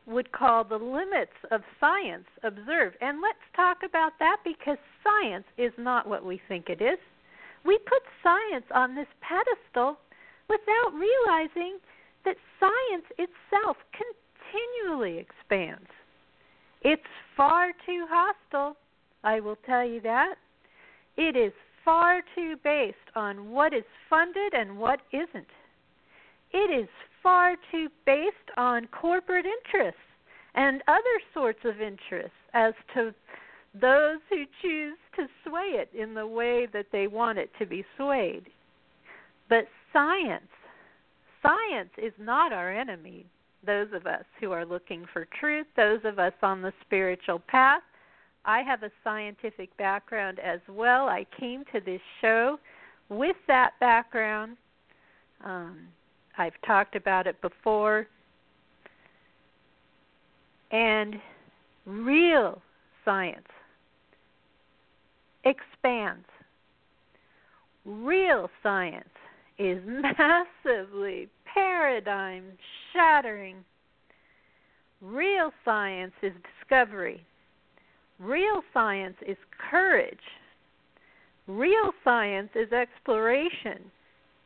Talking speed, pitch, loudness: 105 wpm, 240 Hz, -27 LUFS